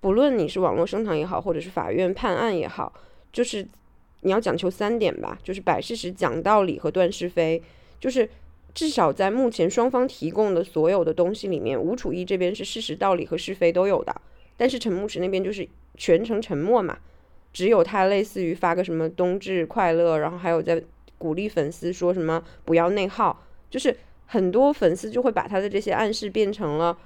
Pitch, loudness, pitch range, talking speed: 185 Hz, -24 LUFS, 170-210 Hz, 305 characters per minute